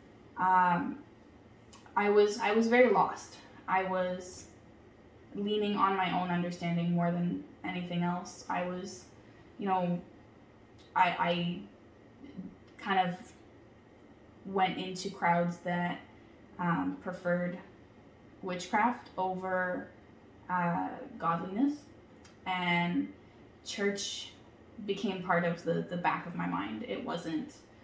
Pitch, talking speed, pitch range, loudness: 180 Hz, 105 wpm, 165-190 Hz, -32 LUFS